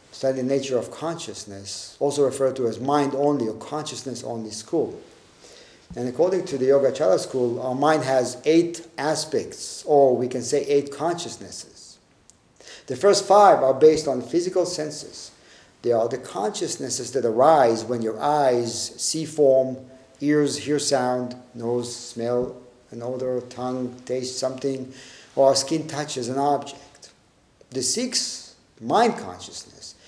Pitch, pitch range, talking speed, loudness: 130 Hz, 125-145 Hz, 140 wpm, -23 LUFS